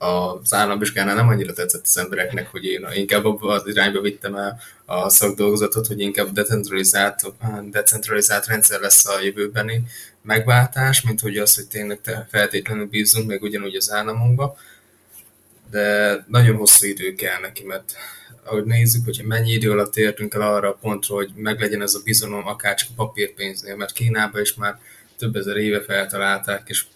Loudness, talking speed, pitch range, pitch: -18 LUFS, 160 wpm, 100-110 Hz, 105 Hz